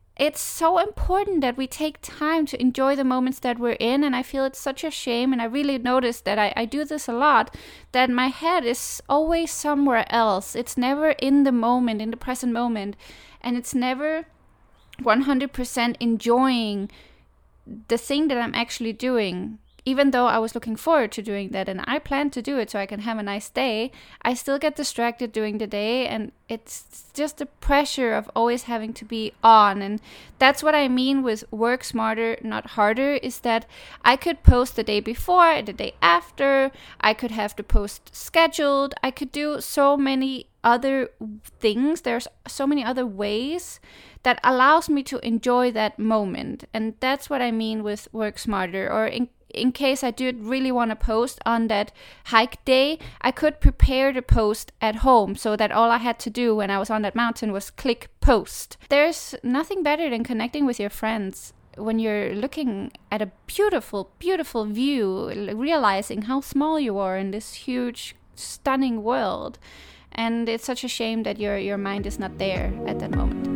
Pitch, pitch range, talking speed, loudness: 245 Hz, 220-275 Hz, 190 wpm, -23 LUFS